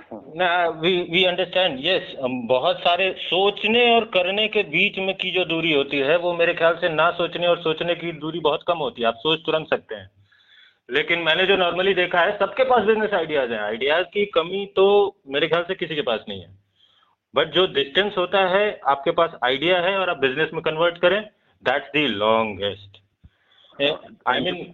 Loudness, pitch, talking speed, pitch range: -21 LUFS, 175 Hz, 190 wpm, 150-190 Hz